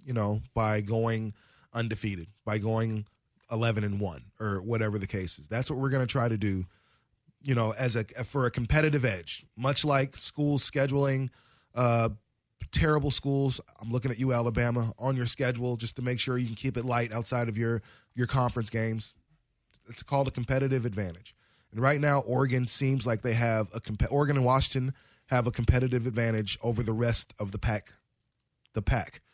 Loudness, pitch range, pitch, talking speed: -29 LUFS, 110-130 Hz, 120 Hz, 185 wpm